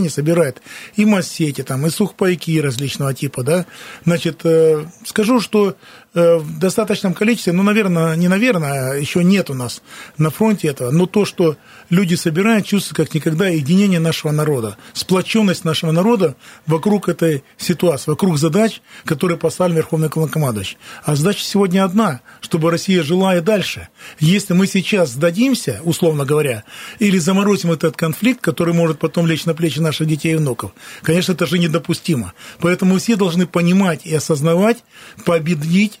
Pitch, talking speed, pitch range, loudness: 170 Hz, 150 wpm, 160-195 Hz, -16 LUFS